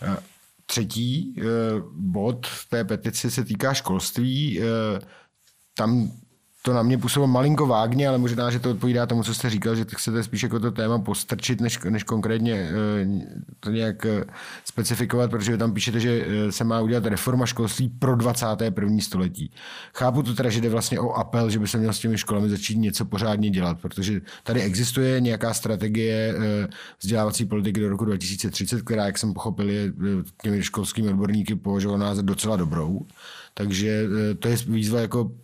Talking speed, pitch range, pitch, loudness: 165 wpm, 105-120 Hz, 110 Hz, -24 LUFS